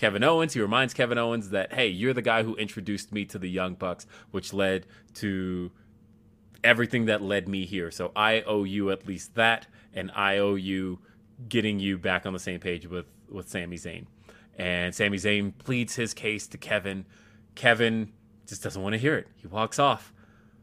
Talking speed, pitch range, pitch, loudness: 190 wpm, 95-110 Hz, 105 Hz, -27 LUFS